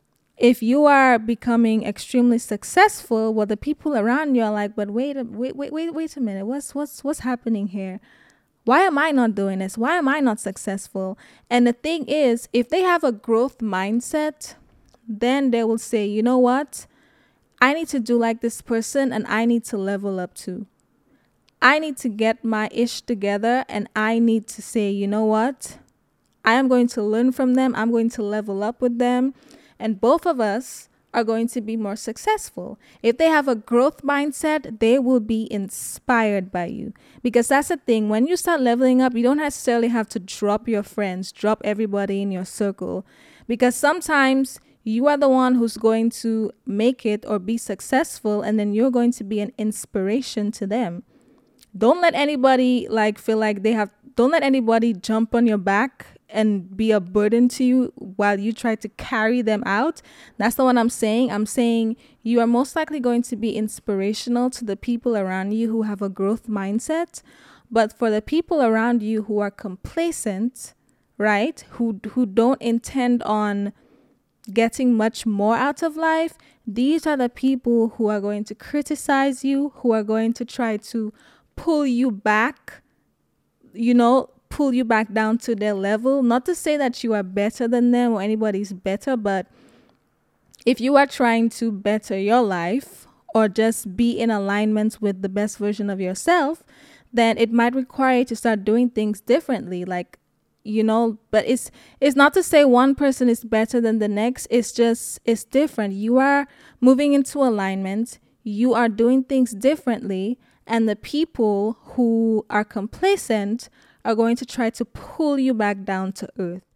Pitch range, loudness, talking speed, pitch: 215-260 Hz, -21 LUFS, 180 wpm, 230 Hz